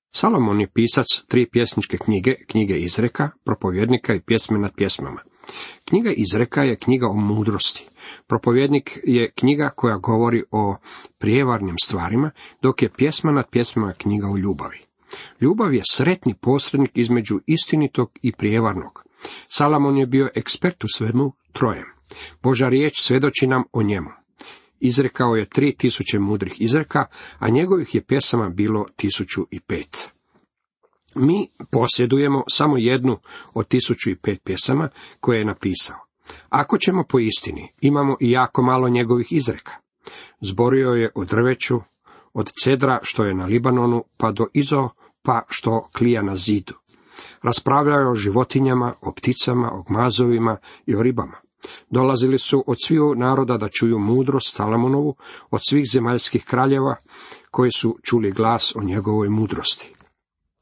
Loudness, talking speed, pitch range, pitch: -20 LUFS, 140 wpm, 110-135 Hz, 120 Hz